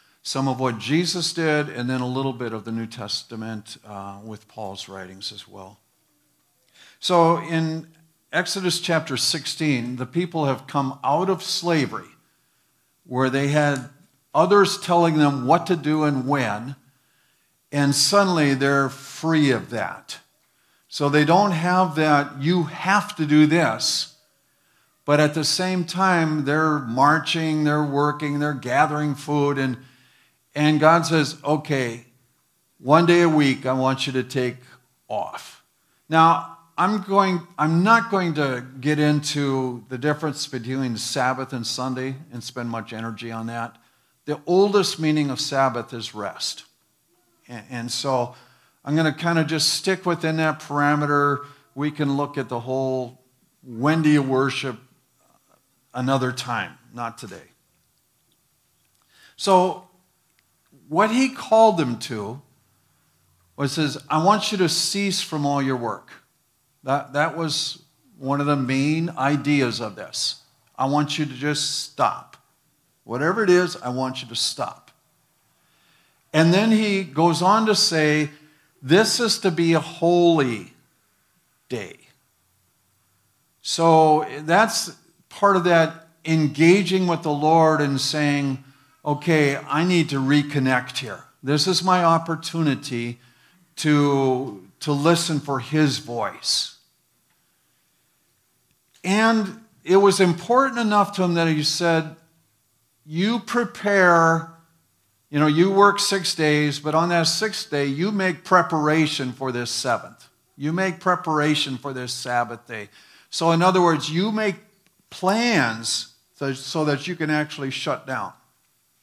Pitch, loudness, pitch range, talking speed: 150 Hz, -21 LUFS, 130-170 Hz, 140 wpm